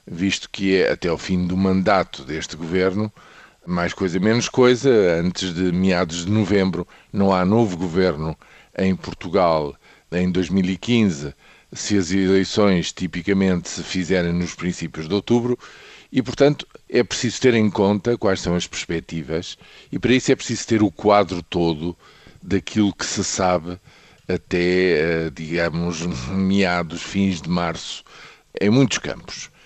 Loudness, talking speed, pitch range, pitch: -20 LUFS, 140 wpm, 85-105 Hz, 95 Hz